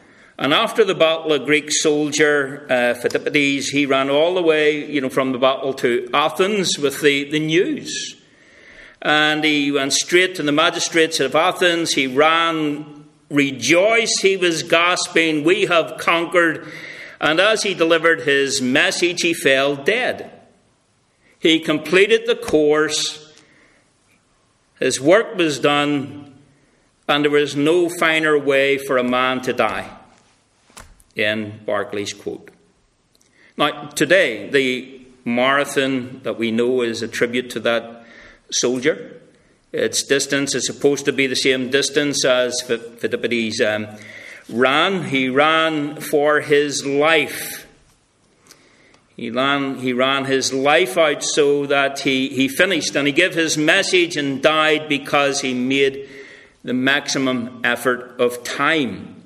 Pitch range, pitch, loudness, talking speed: 135-160 Hz, 145 Hz, -17 LUFS, 135 wpm